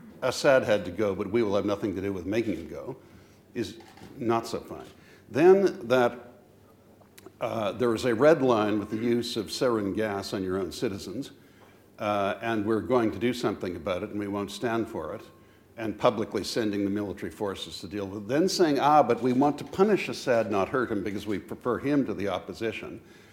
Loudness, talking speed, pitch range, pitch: -27 LUFS, 210 wpm, 100-120 Hz, 110 Hz